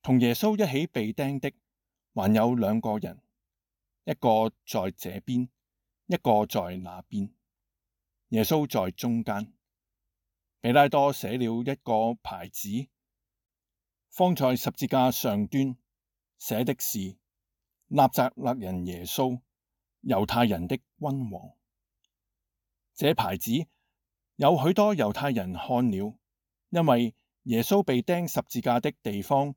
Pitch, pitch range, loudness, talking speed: 120 Hz, 100-135 Hz, -27 LUFS, 165 characters per minute